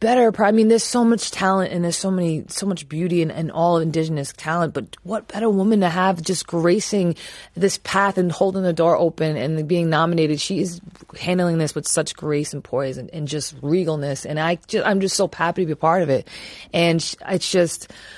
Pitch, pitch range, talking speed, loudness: 170 Hz, 160-190 Hz, 215 wpm, -20 LUFS